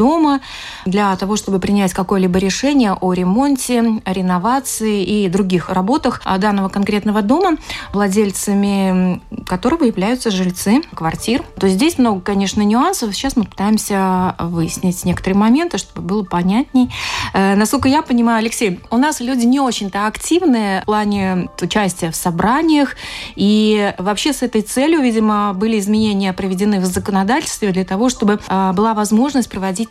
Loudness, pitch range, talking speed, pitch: -16 LUFS, 190-245 Hz, 140 wpm, 210 Hz